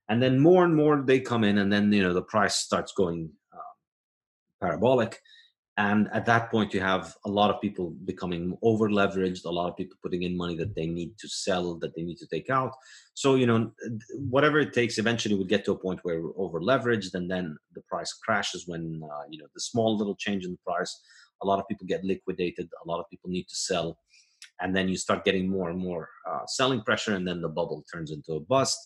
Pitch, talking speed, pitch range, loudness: 100 Hz, 235 wpm, 90-115 Hz, -27 LUFS